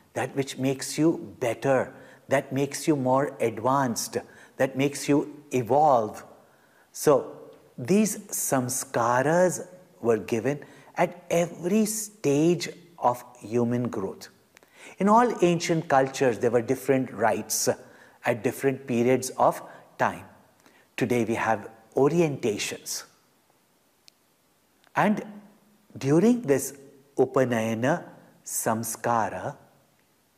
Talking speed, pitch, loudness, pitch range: 95 wpm, 135 Hz, -26 LUFS, 125-170 Hz